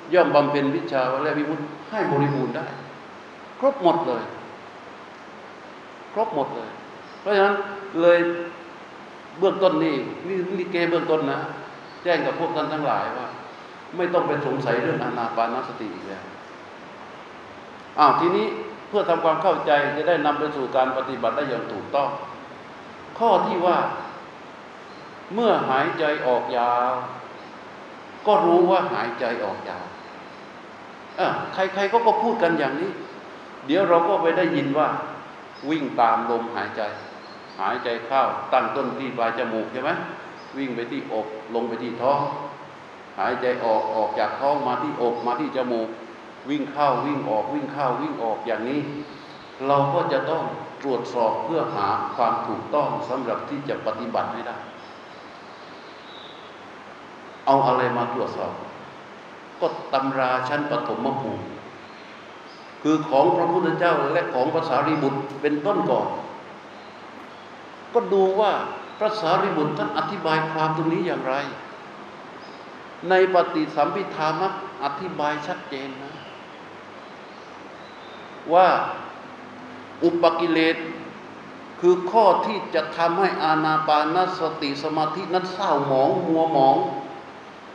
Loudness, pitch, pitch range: -23 LUFS, 155 Hz, 135-175 Hz